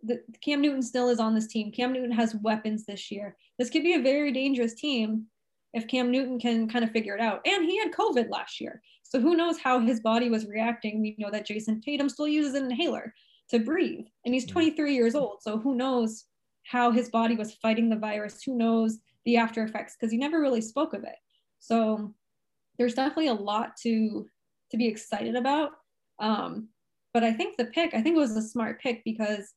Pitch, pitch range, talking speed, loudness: 235 Hz, 220-270 Hz, 215 wpm, -28 LUFS